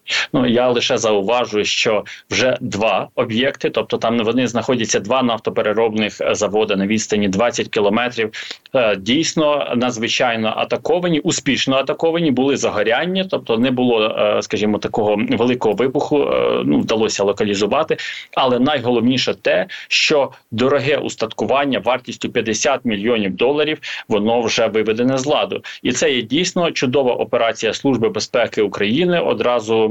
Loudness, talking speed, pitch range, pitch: -17 LUFS, 120 wpm, 110-150 Hz, 120 Hz